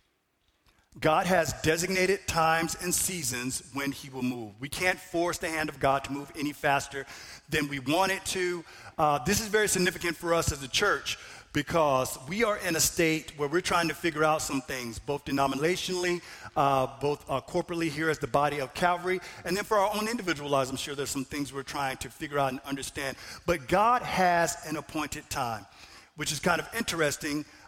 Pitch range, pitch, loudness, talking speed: 140-175 Hz, 155 Hz, -29 LUFS, 200 wpm